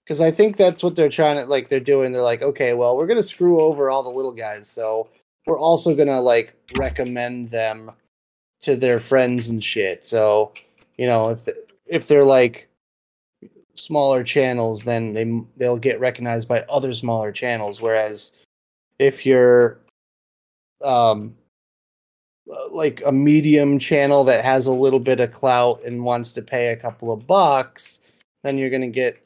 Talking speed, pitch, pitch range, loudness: 170 wpm, 125 Hz, 115-140 Hz, -19 LUFS